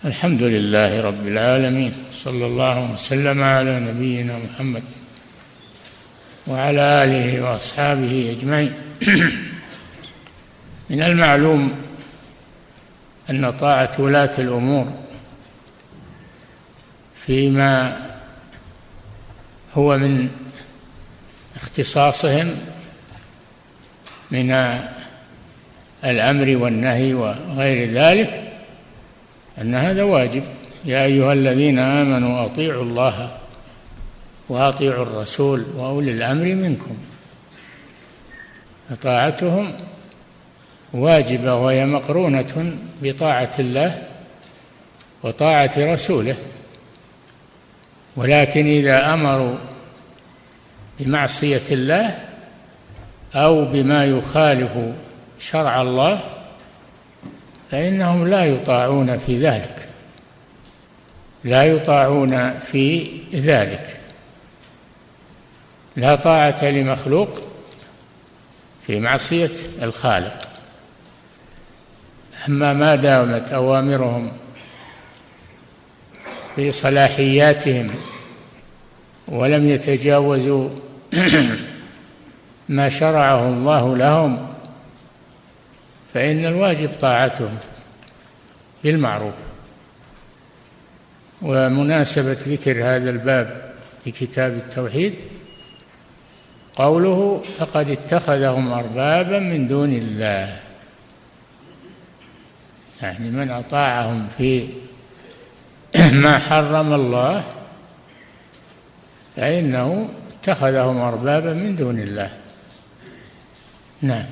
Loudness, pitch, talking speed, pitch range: -18 LUFS, 135 Hz, 65 wpm, 125-145 Hz